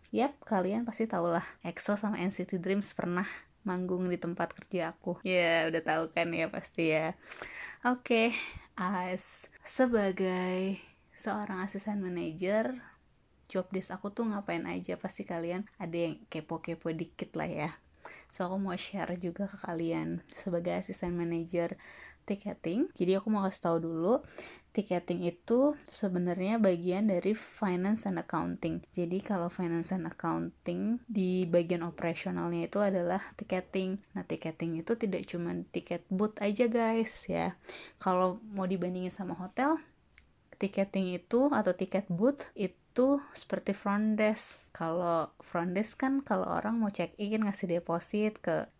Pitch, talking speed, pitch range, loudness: 185 Hz, 145 wpm, 170-210 Hz, -33 LUFS